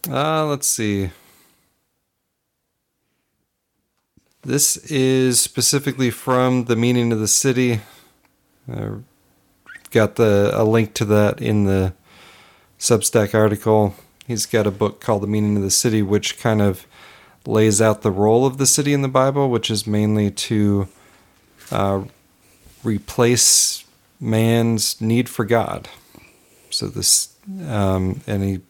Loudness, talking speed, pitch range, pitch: -18 LUFS, 130 wpm, 100-125 Hz, 110 Hz